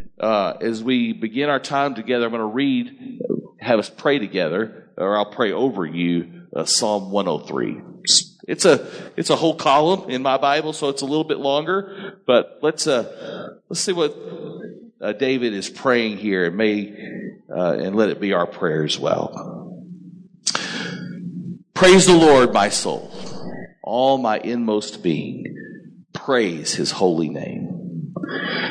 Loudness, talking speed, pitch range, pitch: -20 LUFS, 155 wpm, 110-180 Hz, 140 Hz